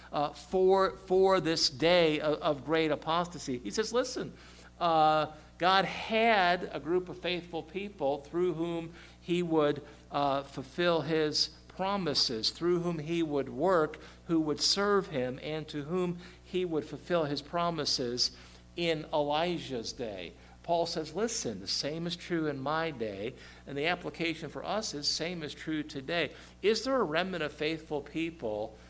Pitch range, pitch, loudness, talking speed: 145-175 Hz, 160 Hz, -31 LUFS, 155 wpm